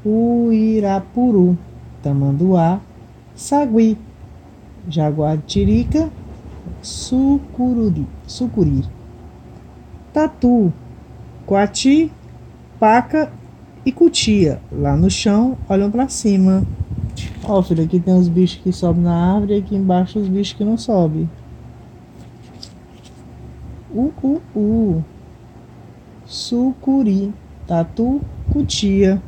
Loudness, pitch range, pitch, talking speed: -17 LUFS, 170-235 Hz, 200 Hz, 80 wpm